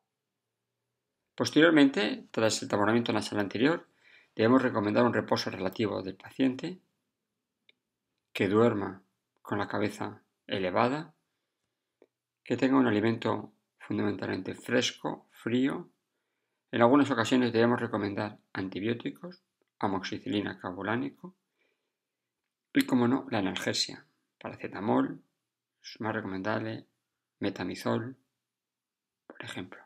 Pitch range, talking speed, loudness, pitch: 105-130 Hz, 95 wpm, -29 LUFS, 115 Hz